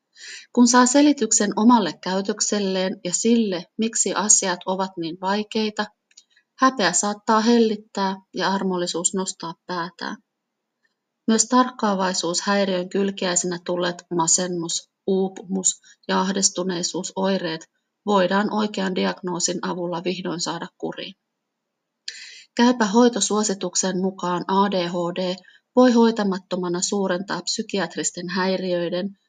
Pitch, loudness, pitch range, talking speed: 190 Hz, -21 LUFS, 180-215 Hz, 90 wpm